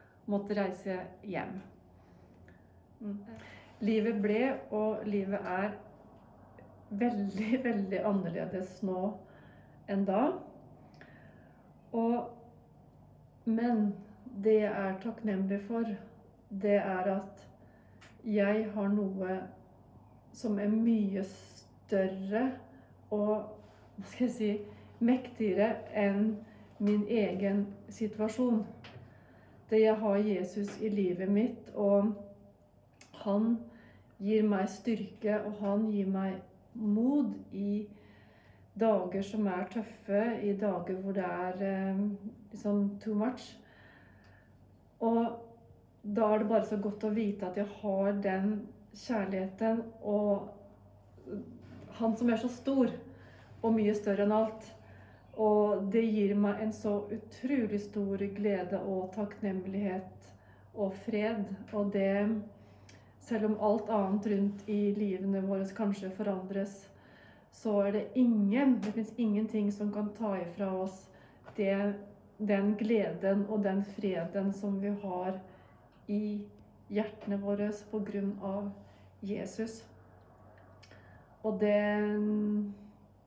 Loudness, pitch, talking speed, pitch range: -33 LUFS, 205 Hz, 110 wpm, 190-215 Hz